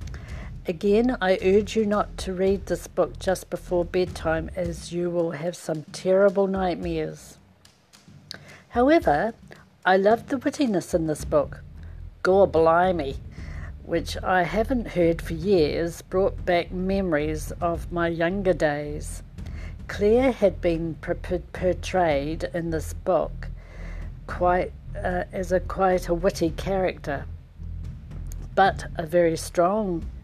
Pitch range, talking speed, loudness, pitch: 155-190 Hz, 120 wpm, -24 LUFS, 175 Hz